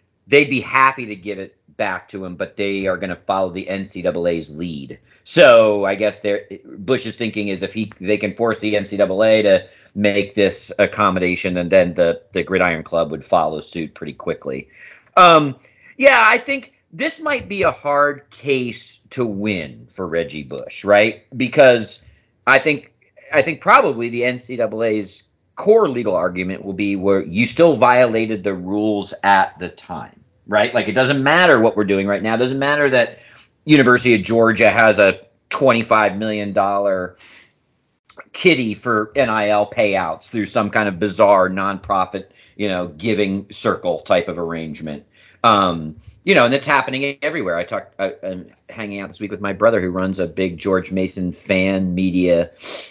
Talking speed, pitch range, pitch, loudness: 170 wpm, 95-125 Hz, 105 Hz, -17 LUFS